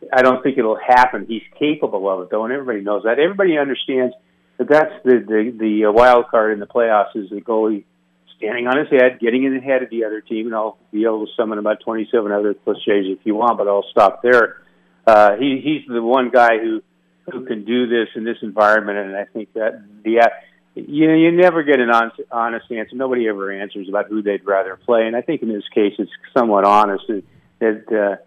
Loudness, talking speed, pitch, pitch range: -17 LUFS, 225 wpm, 110 Hz, 105-125 Hz